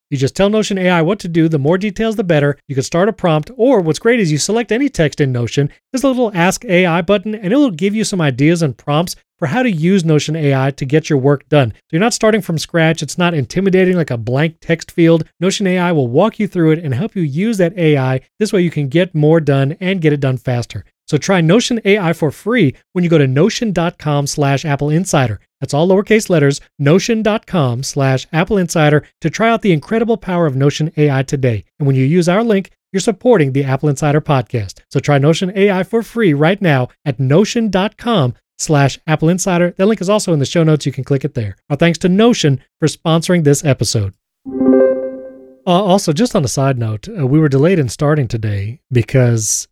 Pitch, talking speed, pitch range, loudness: 160 Hz, 225 wpm, 140-190 Hz, -14 LUFS